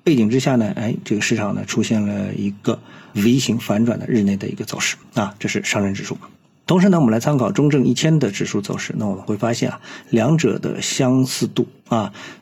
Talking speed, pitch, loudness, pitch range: 320 characters per minute, 120 Hz, -19 LUFS, 105-135 Hz